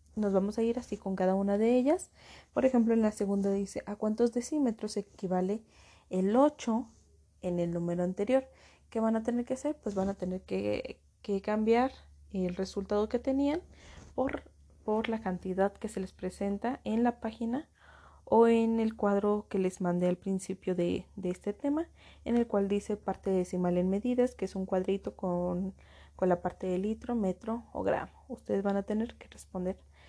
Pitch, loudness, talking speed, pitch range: 205 Hz, -32 LUFS, 185 wpm, 185-230 Hz